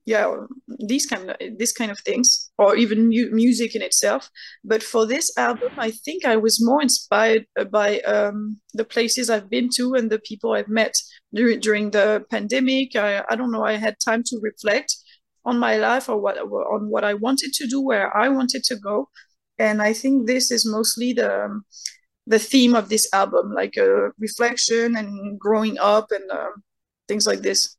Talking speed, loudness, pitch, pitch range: 190 wpm, -20 LUFS, 230 Hz, 215-250 Hz